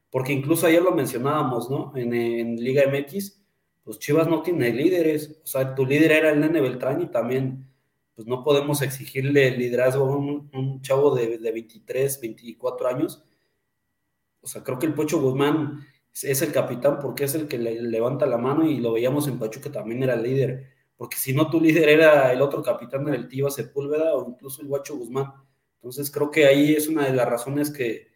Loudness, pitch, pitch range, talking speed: -23 LUFS, 140 Hz, 130-150 Hz, 200 wpm